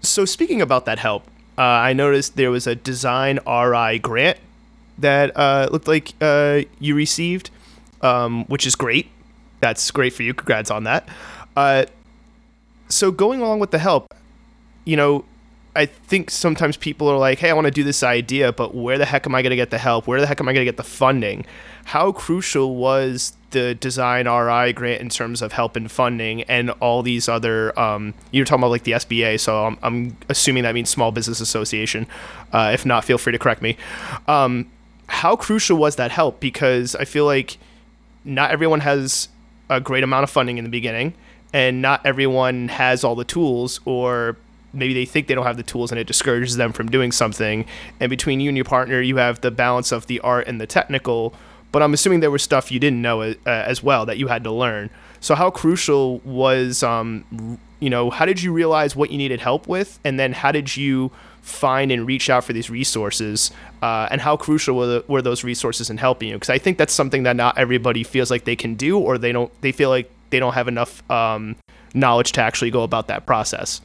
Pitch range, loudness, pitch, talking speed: 120-145 Hz, -19 LUFS, 130 Hz, 215 wpm